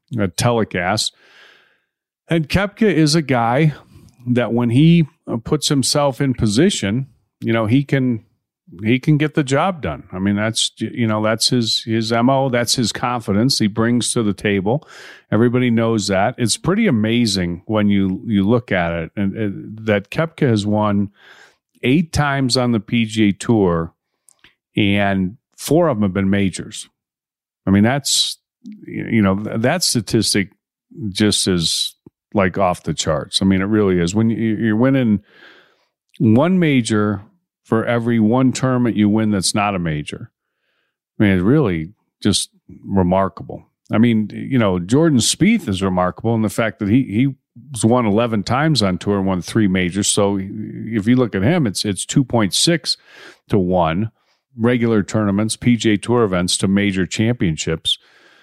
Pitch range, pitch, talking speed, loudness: 100-125 Hz, 110 Hz, 160 wpm, -17 LUFS